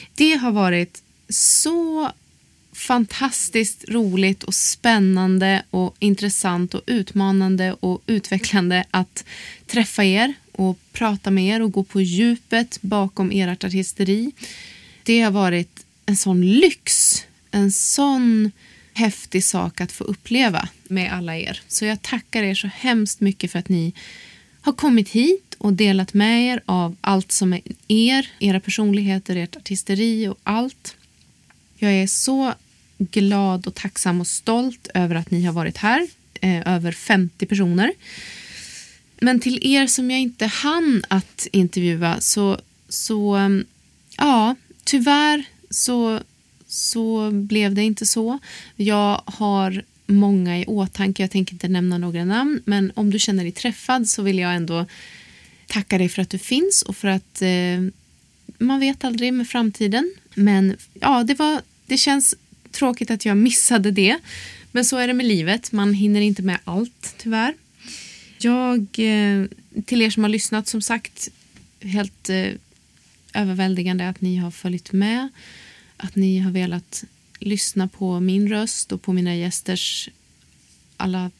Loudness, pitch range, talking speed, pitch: -20 LUFS, 190-230 Hz, 145 wpm, 205 Hz